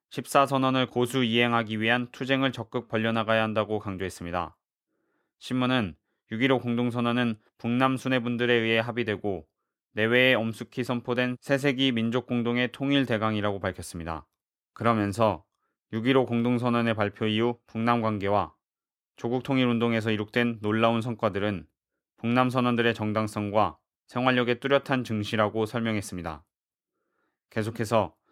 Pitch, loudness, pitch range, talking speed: 115 Hz, -26 LUFS, 105-125 Hz, 310 characters per minute